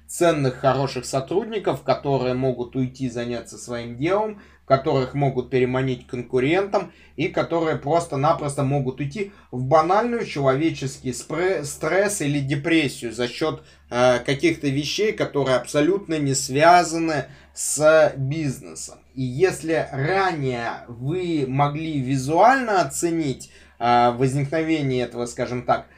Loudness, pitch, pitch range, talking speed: -22 LUFS, 140 Hz, 130-160 Hz, 110 wpm